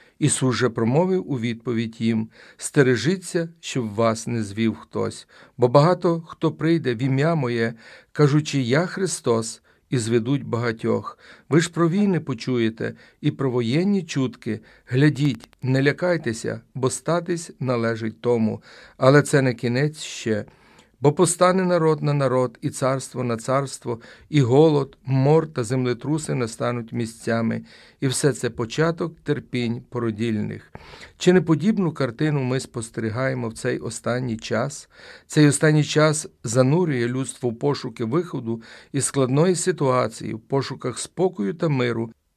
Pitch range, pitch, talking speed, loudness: 120-155 Hz, 130 Hz, 135 wpm, -22 LUFS